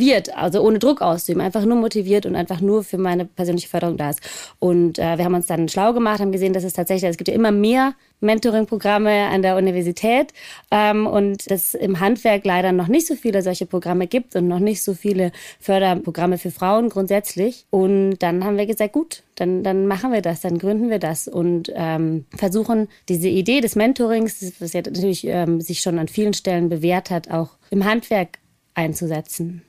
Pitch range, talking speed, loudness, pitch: 175-215 Hz, 200 wpm, -19 LUFS, 190 Hz